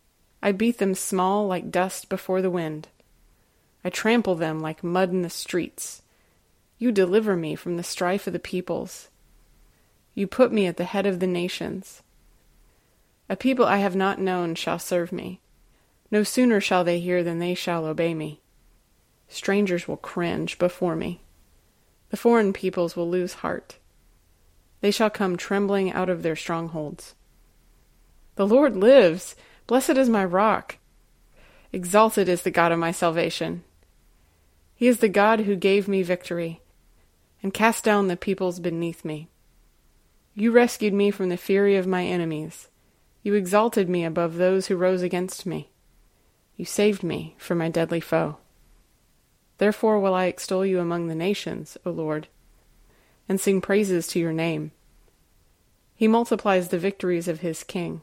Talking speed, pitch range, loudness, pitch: 155 wpm, 170-200 Hz, -24 LUFS, 185 Hz